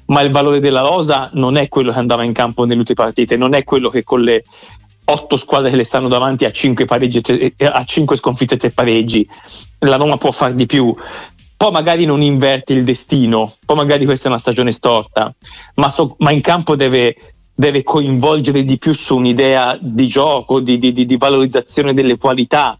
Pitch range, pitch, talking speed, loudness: 125-145 Hz, 130 Hz, 190 wpm, -13 LUFS